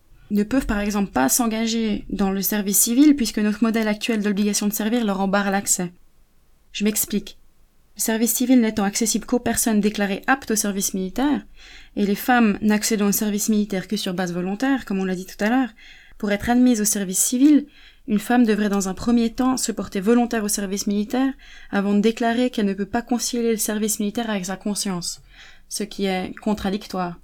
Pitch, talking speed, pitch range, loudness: 210 Hz, 195 wpm, 200-235 Hz, -21 LUFS